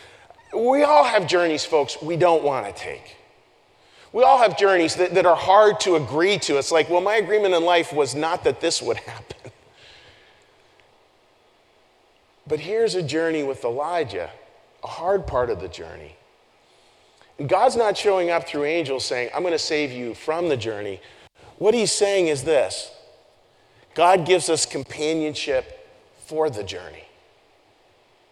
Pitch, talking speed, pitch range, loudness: 165 Hz, 155 wpm, 150-195 Hz, -21 LUFS